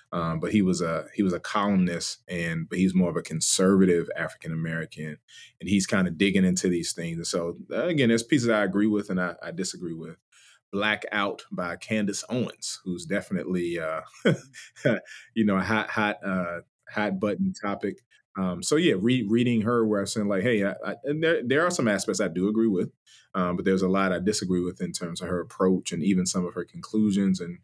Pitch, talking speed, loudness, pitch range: 95 Hz, 215 wpm, -26 LUFS, 90-105 Hz